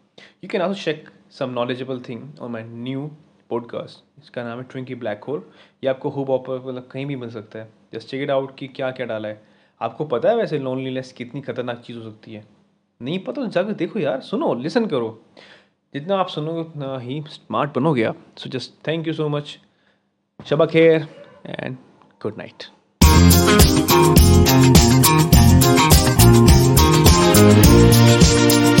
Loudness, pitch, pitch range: -16 LUFS, 130 Hz, 110-140 Hz